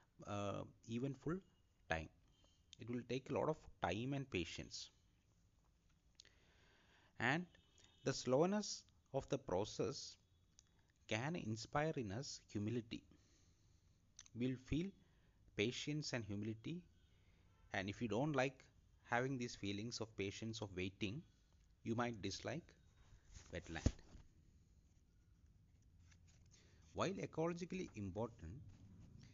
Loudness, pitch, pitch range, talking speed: -45 LUFS, 100 Hz, 90-120 Hz, 100 wpm